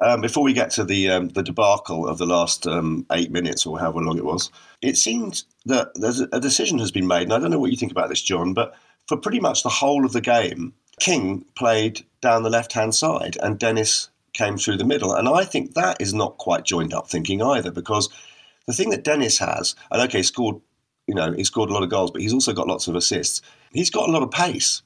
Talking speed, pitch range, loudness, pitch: 250 wpm, 85-115 Hz, -21 LUFS, 105 Hz